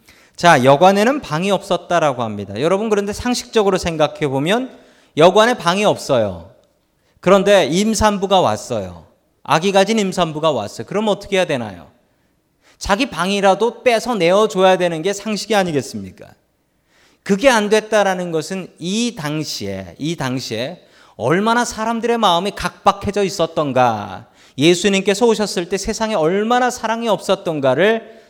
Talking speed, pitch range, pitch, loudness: 320 characters per minute, 160-215 Hz, 195 Hz, -16 LUFS